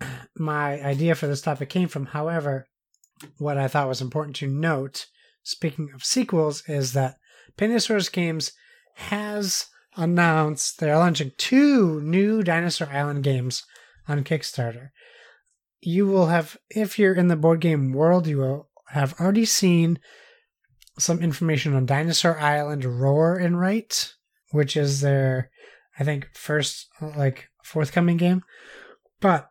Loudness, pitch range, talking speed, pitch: -23 LUFS, 140-180 Hz, 135 wpm, 155 Hz